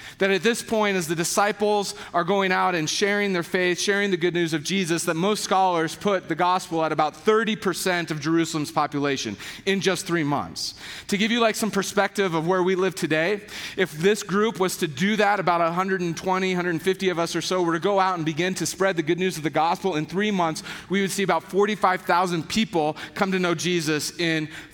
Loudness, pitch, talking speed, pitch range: -23 LUFS, 185 Hz, 215 wpm, 165-195 Hz